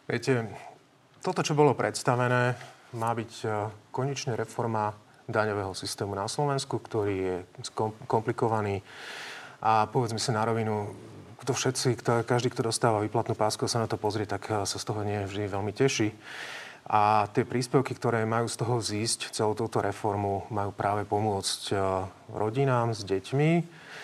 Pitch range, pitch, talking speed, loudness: 105-125 Hz, 115 Hz, 140 wpm, -29 LUFS